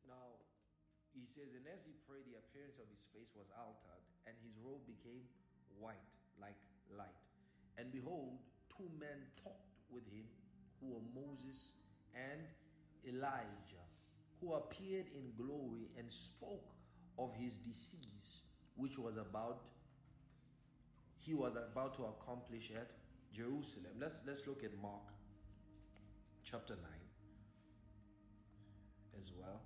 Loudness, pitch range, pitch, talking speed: -50 LUFS, 100-130 Hz, 115 Hz, 125 wpm